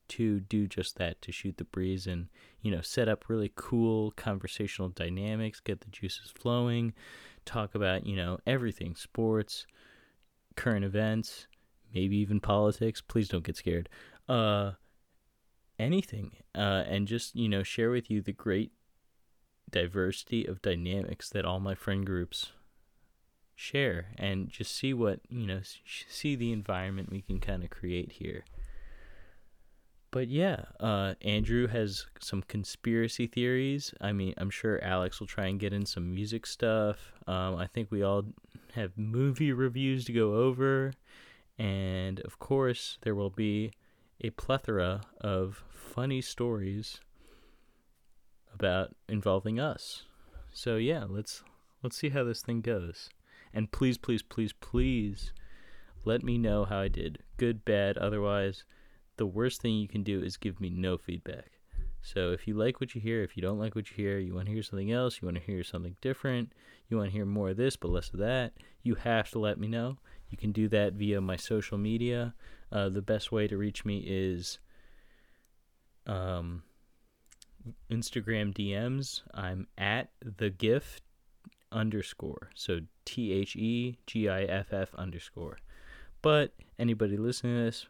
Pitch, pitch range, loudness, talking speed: 105 Hz, 95-115 Hz, -33 LUFS, 160 wpm